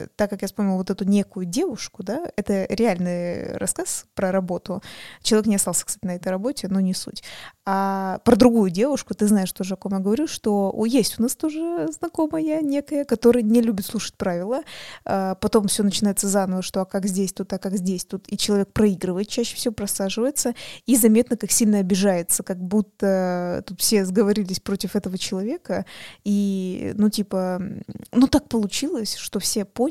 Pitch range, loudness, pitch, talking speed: 190-230 Hz, -22 LUFS, 205 Hz, 180 wpm